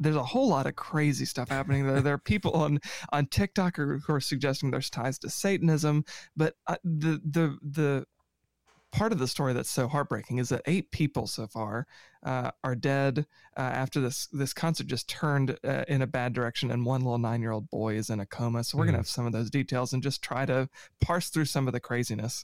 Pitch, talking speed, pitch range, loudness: 135 Hz, 220 wpm, 125-150 Hz, -30 LUFS